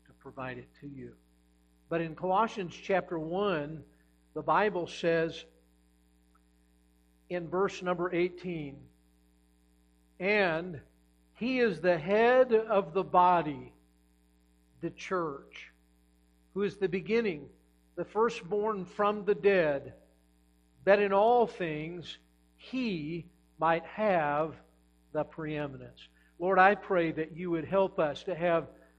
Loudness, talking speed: -30 LUFS, 110 wpm